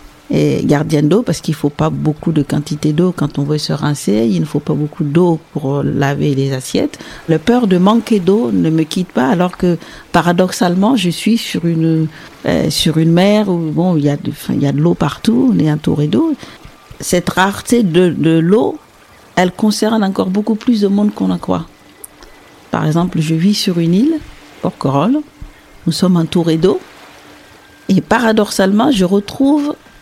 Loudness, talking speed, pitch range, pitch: -14 LUFS, 180 wpm, 155-205 Hz, 175 Hz